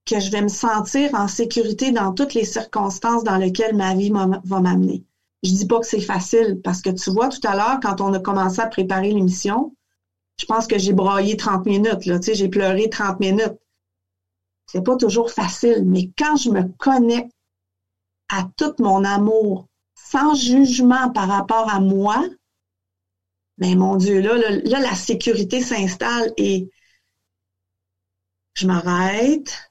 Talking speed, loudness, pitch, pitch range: 170 wpm, -19 LUFS, 200 Hz, 185-230 Hz